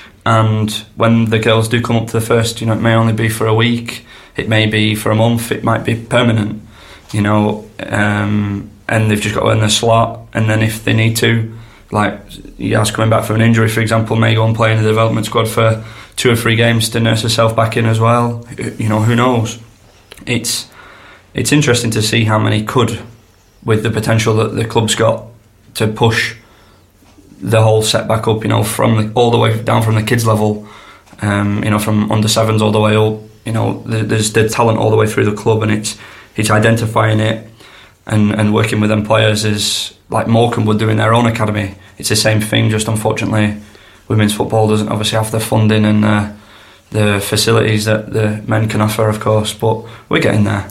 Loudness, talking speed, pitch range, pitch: -14 LUFS, 215 wpm, 105-115 Hz, 110 Hz